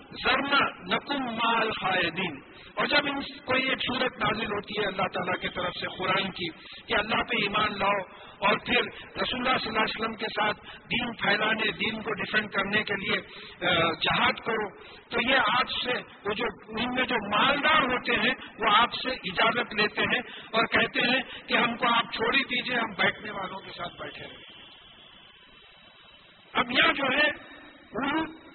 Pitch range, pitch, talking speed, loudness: 200-250 Hz, 220 Hz, 175 wpm, -26 LUFS